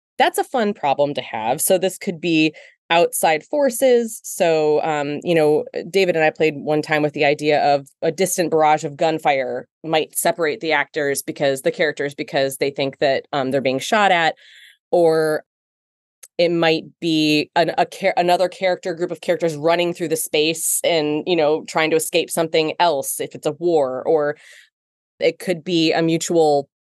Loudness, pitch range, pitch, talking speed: -19 LUFS, 150-175 Hz, 160 Hz, 180 wpm